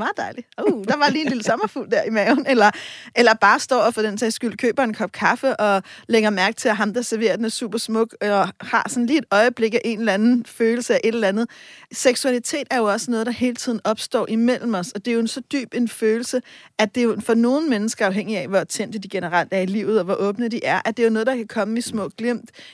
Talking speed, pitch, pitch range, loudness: 275 wpm, 230 Hz, 215-245 Hz, -20 LUFS